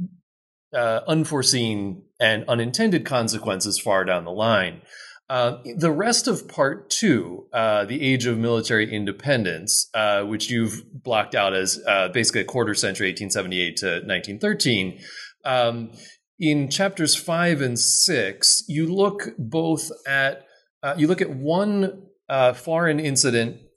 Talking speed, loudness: 135 wpm, -21 LUFS